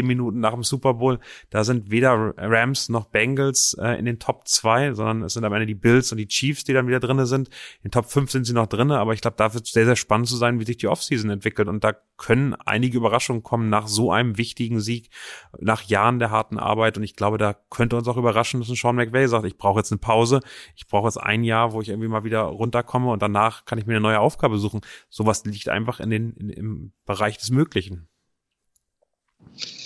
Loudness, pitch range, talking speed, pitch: -22 LUFS, 110-125 Hz, 240 wpm, 115 Hz